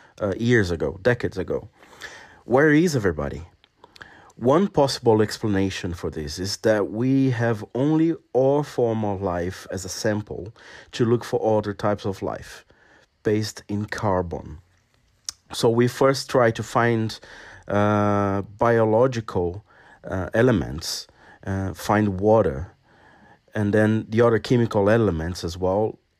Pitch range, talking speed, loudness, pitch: 95-120 Hz, 130 wpm, -22 LUFS, 105 Hz